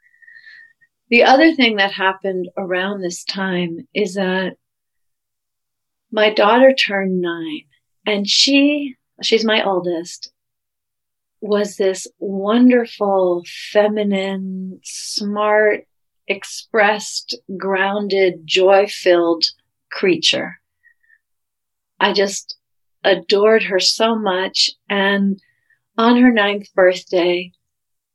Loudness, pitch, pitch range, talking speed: -16 LUFS, 200 Hz, 185-225 Hz, 85 wpm